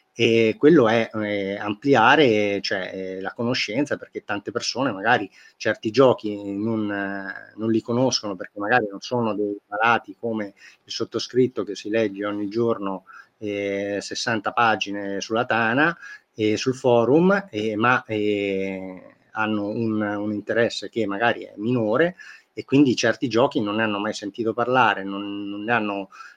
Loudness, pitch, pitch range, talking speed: -22 LUFS, 105 Hz, 100-115 Hz, 155 wpm